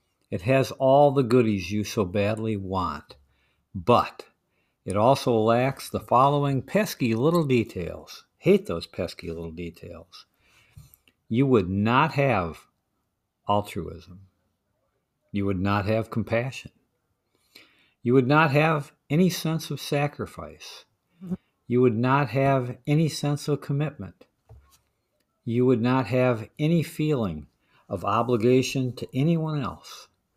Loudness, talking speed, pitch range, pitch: -24 LUFS, 120 wpm, 100-145 Hz, 125 Hz